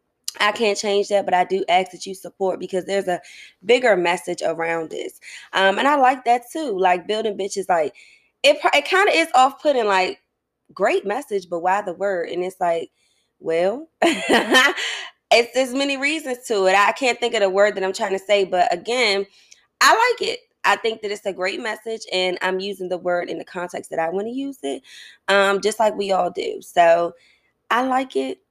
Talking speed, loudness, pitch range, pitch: 210 wpm, -20 LUFS, 185-245 Hz, 200 Hz